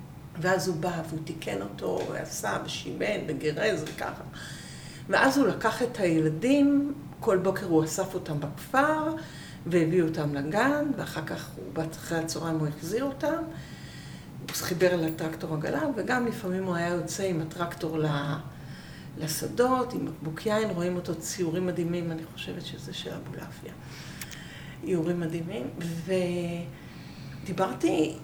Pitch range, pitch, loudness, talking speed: 160-195 Hz, 170 Hz, -29 LUFS, 130 wpm